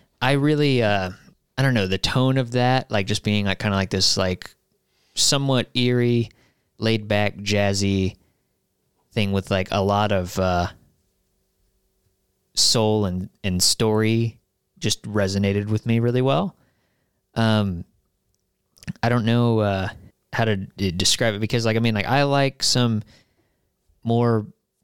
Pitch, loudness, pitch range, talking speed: 110 Hz, -21 LUFS, 95-120 Hz, 145 wpm